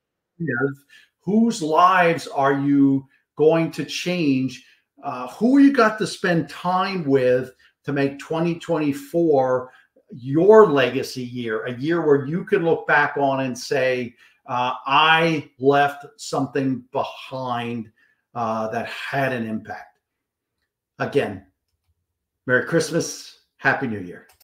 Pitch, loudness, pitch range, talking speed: 140 Hz, -21 LUFS, 125-165 Hz, 120 wpm